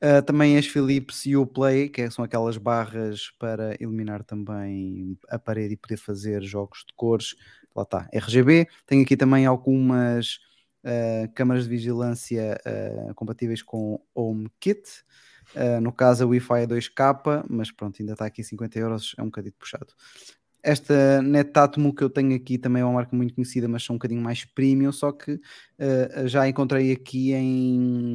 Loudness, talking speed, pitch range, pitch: -24 LUFS, 175 wpm, 115-135 Hz, 120 Hz